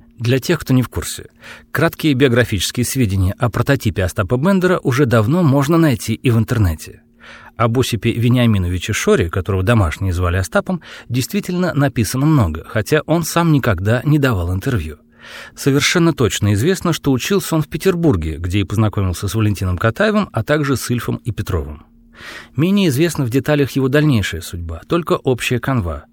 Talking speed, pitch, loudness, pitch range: 155 wpm, 120 Hz, -17 LUFS, 105-150 Hz